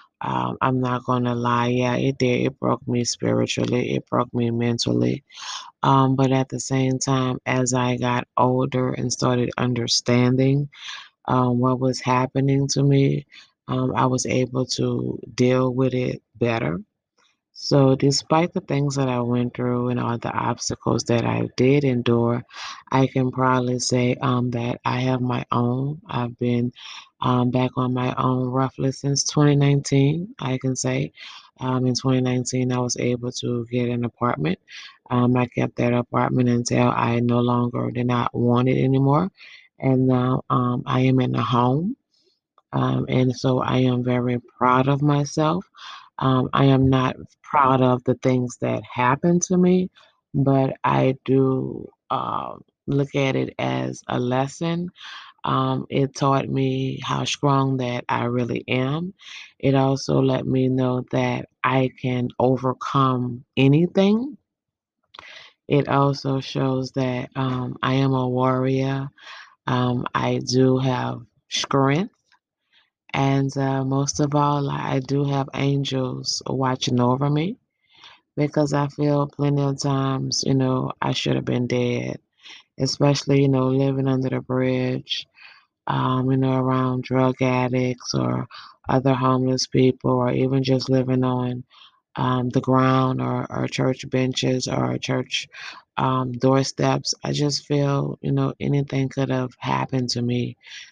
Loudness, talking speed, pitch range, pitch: -22 LUFS, 150 wpm, 125-135 Hz, 130 Hz